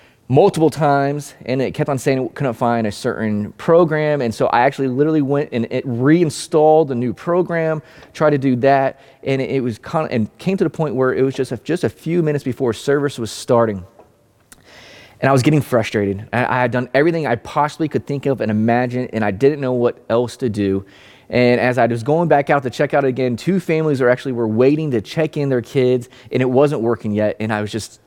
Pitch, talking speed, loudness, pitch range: 130 Hz, 230 wpm, -18 LUFS, 120-150 Hz